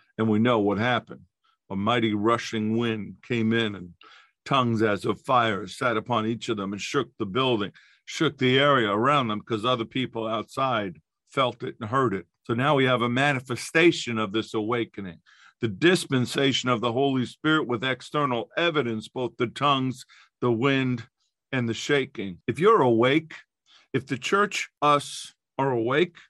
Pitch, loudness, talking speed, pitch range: 120 Hz, -25 LUFS, 170 wpm, 110-135 Hz